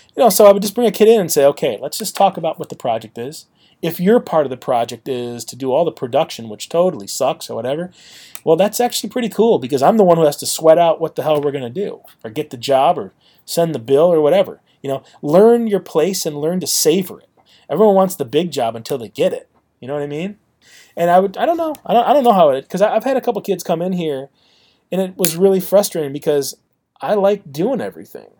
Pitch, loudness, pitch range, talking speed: 170 Hz, -16 LUFS, 145-205 Hz, 265 wpm